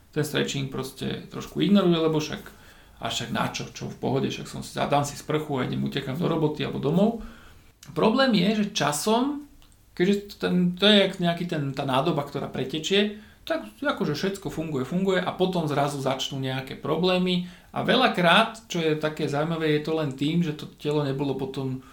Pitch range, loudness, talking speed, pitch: 140-190 Hz, -25 LUFS, 180 wpm, 155 Hz